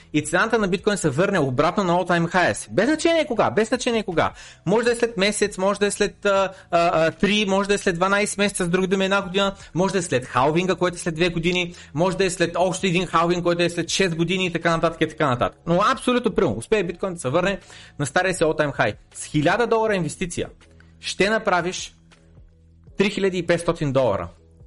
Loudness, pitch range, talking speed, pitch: -21 LUFS, 160-200 Hz, 220 wpm, 180 Hz